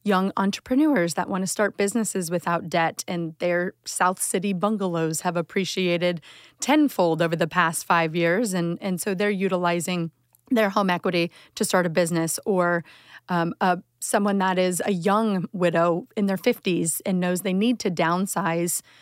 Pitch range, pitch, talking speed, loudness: 170-200 Hz, 180 Hz, 165 wpm, -24 LUFS